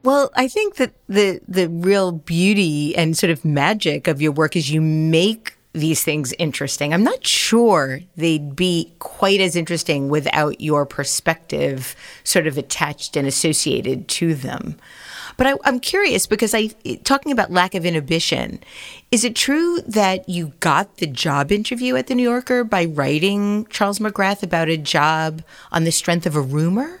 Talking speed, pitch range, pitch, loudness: 170 wpm, 155-210 Hz, 170 Hz, -18 LUFS